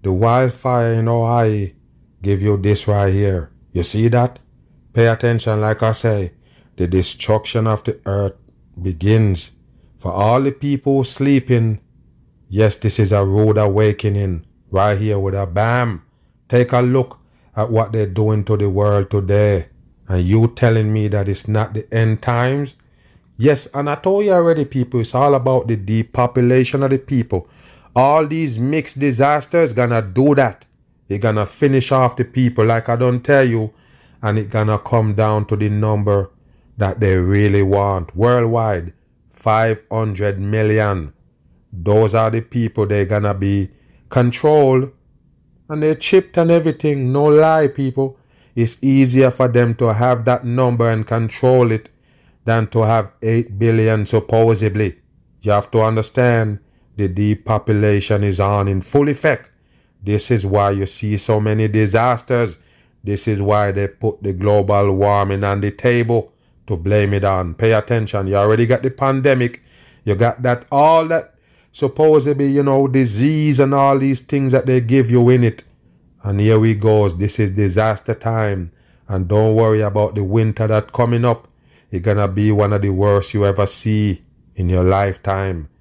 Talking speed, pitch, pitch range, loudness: 160 wpm, 110 Hz, 100-125 Hz, -16 LUFS